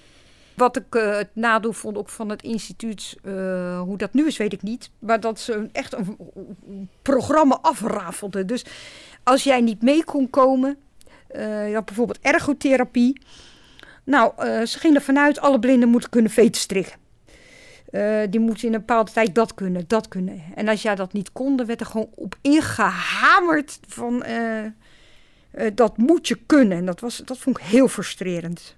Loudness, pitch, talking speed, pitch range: -21 LUFS, 225 Hz, 180 wpm, 210-260 Hz